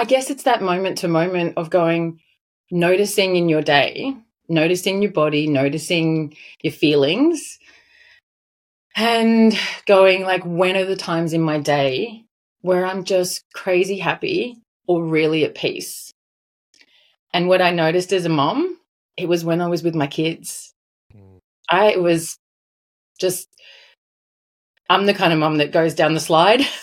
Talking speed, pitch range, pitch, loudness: 150 wpm, 160-200 Hz, 180 Hz, -18 LUFS